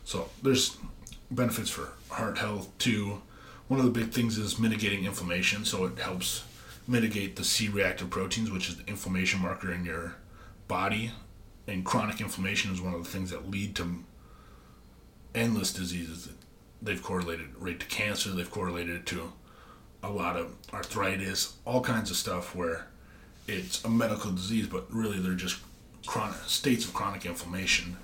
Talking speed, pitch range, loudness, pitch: 155 wpm, 90-105 Hz, -31 LUFS, 95 Hz